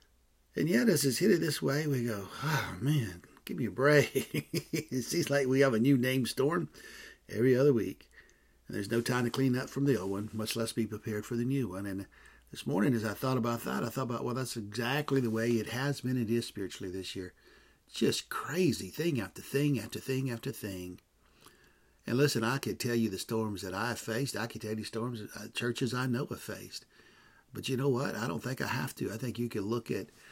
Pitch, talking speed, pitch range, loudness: 120 Hz, 235 wpm, 110-135 Hz, -32 LUFS